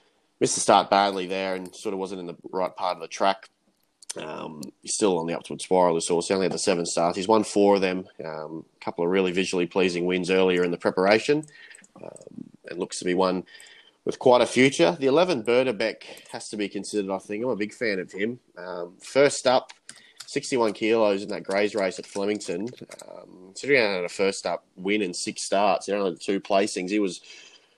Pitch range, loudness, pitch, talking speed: 90-105 Hz, -24 LUFS, 95 Hz, 215 wpm